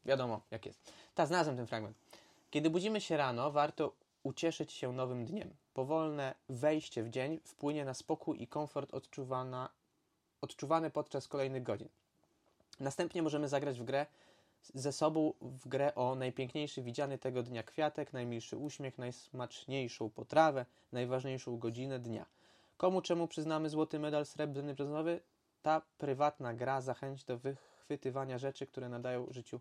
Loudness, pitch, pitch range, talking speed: -38 LUFS, 135 Hz, 125-150 Hz, 140 wpm